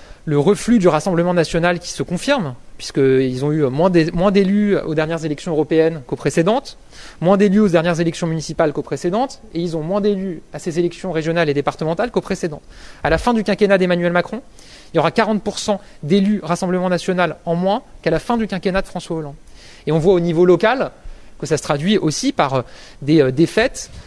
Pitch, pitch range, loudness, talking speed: 175 Hz, 160-200 Hz, -18 LUFS, 195 wpm